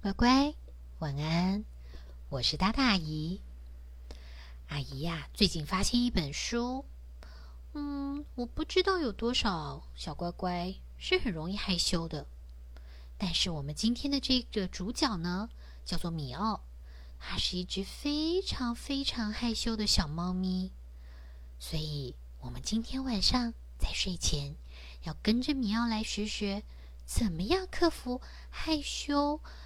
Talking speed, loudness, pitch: 190 characters per minute, -32 LUFS, 180 Hz